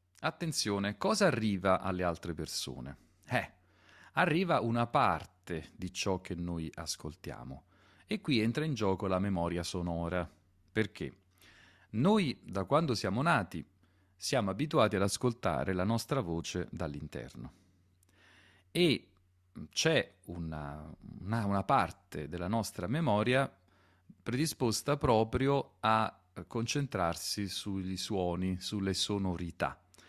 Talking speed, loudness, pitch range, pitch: 110 wpm, -33 LUFS, 90-110 Hz, 95 Hz